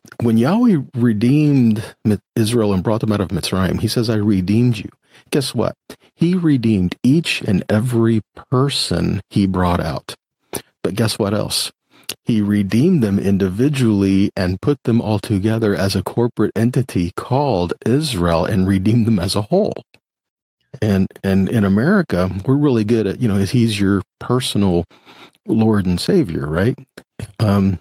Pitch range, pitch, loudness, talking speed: 95-120 Hz, 110 Hz, -17 LUFS, 150 wpm